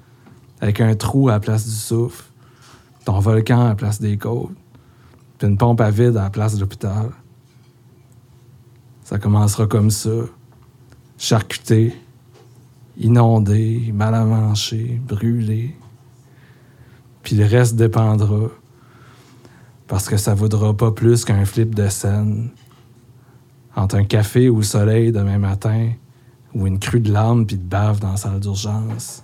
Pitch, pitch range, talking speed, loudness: 115 Hz, 105-125 Hz, 135 wpm, -18 LUFS